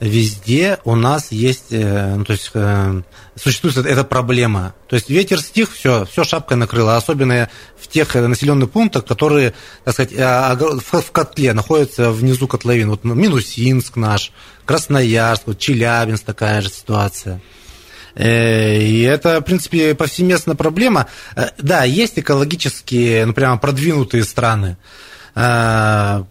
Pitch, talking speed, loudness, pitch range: 120 Hz, 120 wpm, -15 LUFS, 110-145 Hz